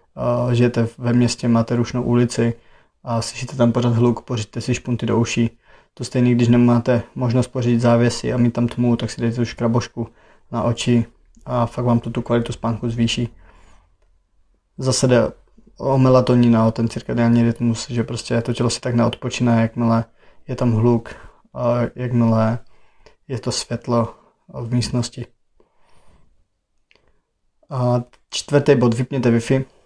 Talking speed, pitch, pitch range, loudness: 145 wpm, 120 Hz, 115-120 Hz, -19 LUFS